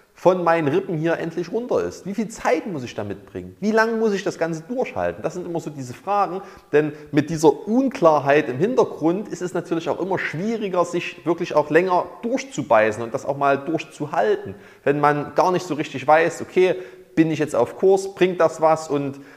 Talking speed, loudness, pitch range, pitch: 205 wpm, -21 LUFS, 150-185 Hz, 165 Hz